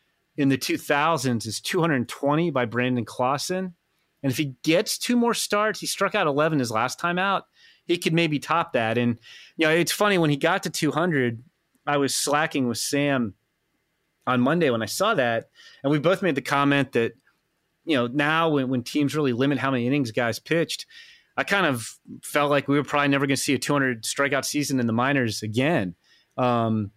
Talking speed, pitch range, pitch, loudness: 215 wpm, 125-165 Hz, 145 Hz, -23 LUFS